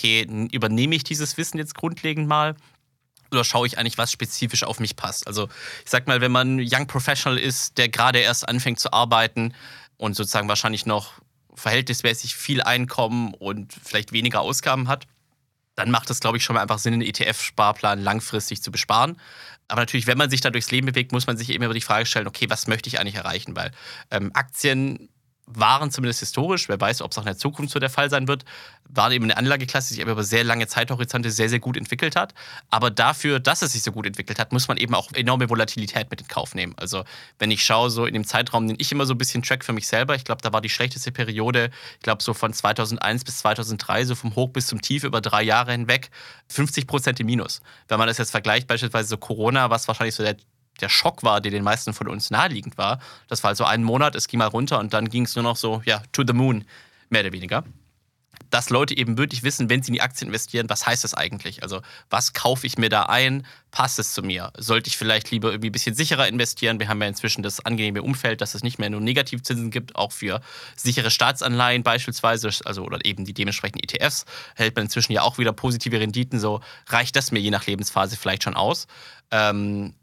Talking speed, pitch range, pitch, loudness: 230 wpm, 110-130 Hz, 120 Hz, -22 LUFS